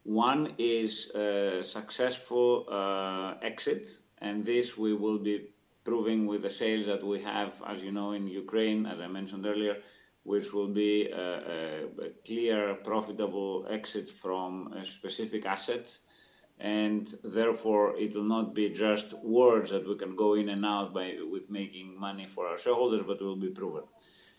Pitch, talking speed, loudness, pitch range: 105 Hz, 165 wpm, -32 LUFS, 100-110 Hz